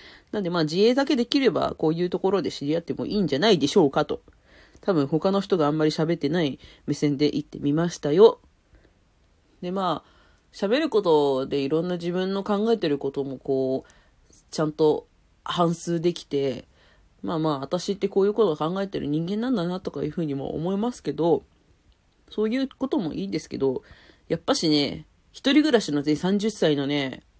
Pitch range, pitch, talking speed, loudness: 145-195 Hz, 165 Hz, 365 characters per minute, -24 LUFS